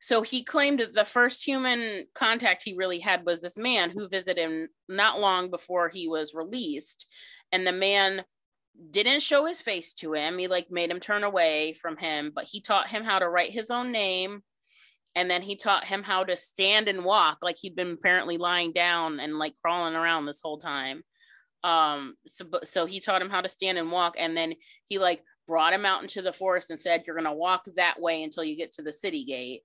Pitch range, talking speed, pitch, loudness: 165-200 Hz, 220 wpm, 180 Hz, -26 LUFS